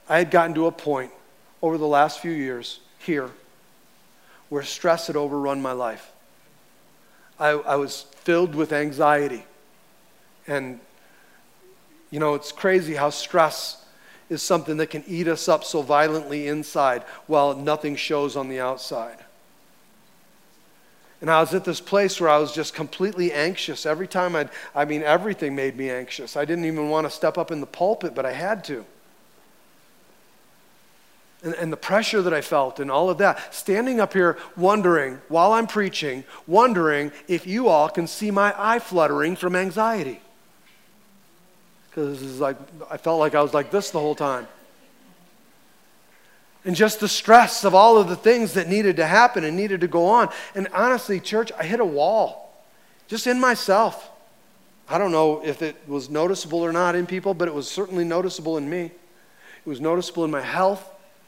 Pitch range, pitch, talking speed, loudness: 150-190 Hz, 165 Hz, 170 wpm, -22 LUFS